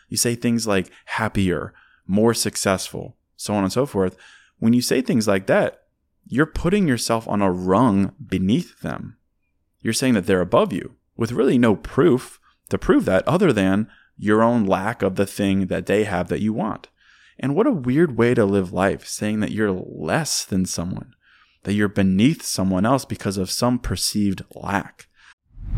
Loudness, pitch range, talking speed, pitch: -21 LUFS, 95-115 Hz, 180 wpm, 100 Hz